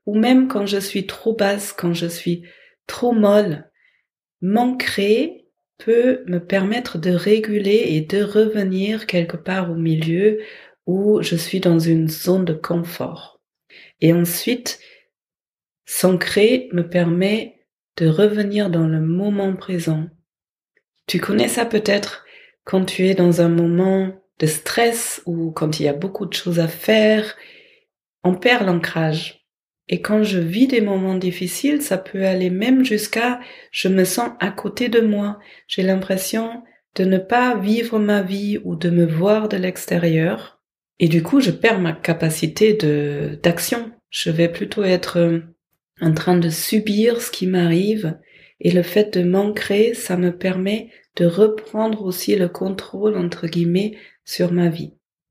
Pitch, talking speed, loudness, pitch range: 190 Hz, 150 wpm, -19 LUFS, 170-215 Hz